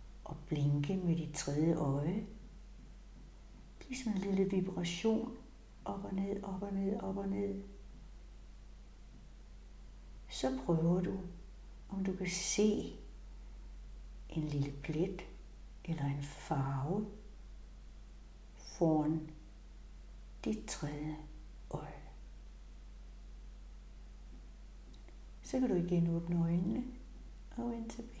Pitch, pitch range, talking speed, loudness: 170 Hz, 140-200 Hz, 100 wpm, -37 LUFS